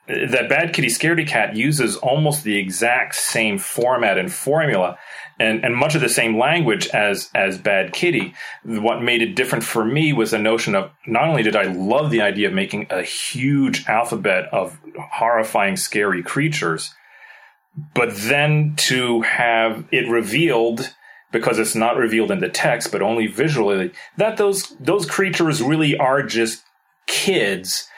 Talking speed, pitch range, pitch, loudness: 160 wpm, 115-160 Hz, 135 Hz, -18 LUFS